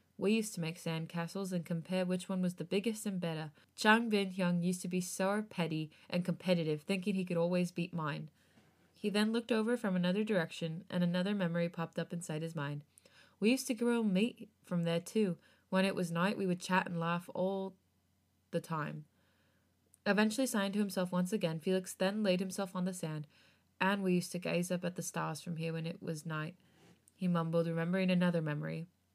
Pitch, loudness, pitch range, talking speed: 180 Hz, -35 LUFS, 165-195 Hz, 205 wpm